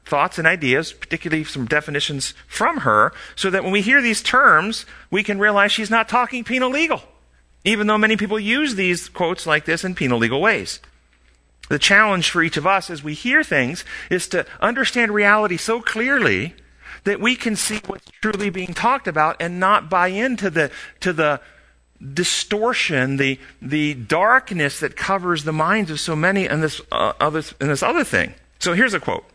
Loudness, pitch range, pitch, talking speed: -19 LUFS, 155-215 Hz, 185 Hz, 185 wpm